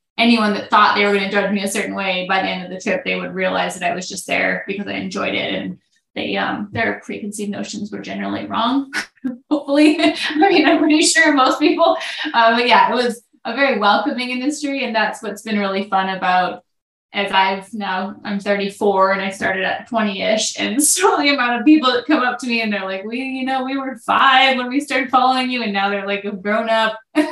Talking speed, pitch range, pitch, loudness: 235 wpm, 200-265 Hz, 225 Hz, -17 LUFS